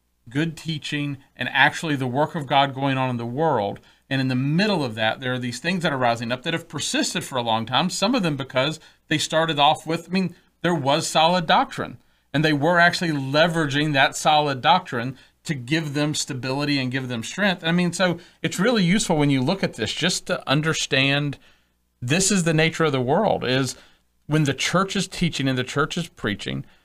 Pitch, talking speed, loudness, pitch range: 150 Hz, 215 wpm, -22 LUFS, 130-170 Hz